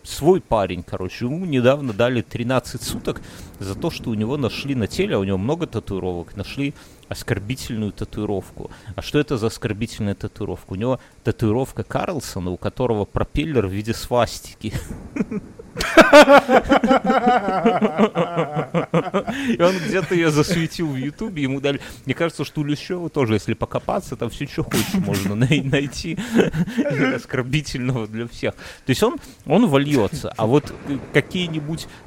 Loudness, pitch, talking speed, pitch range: -20 LUFS, 140 Hz, 140 wpm, 115-170 Hz